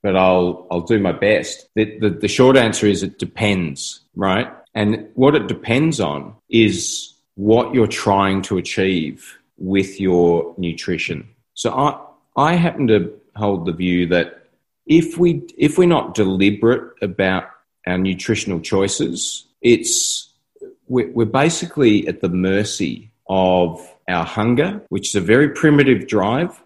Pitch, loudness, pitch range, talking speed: 105 Hz, -18 LUFS, 95-130 Hz, 140 wpm